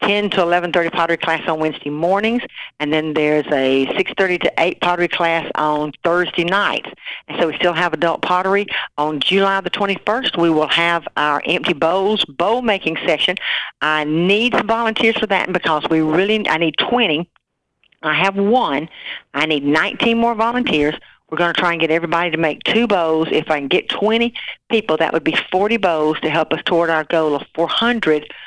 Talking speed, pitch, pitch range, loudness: 190 wpm, 170 Hz, 155-200 Hz, -17 LUFS